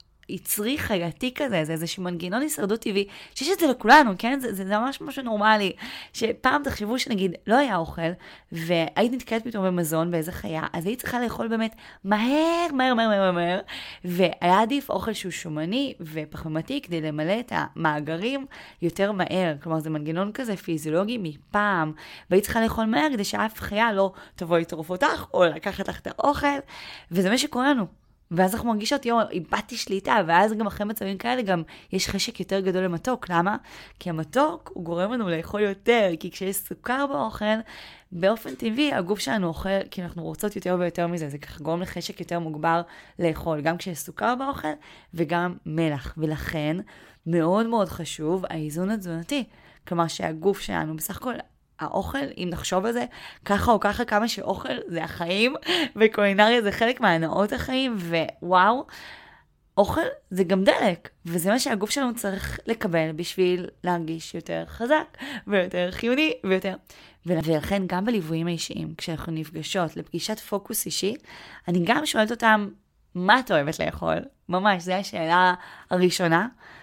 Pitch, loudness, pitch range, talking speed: 195 Hz, -25 LUFS, 170-225 Hz, 155 wpm